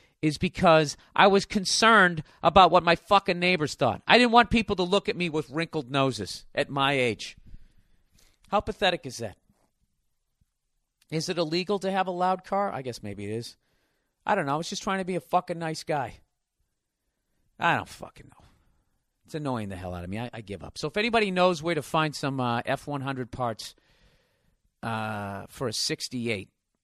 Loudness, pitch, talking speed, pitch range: -25 LUFS, 155 Hz, 190 wpm, 120-185 Hz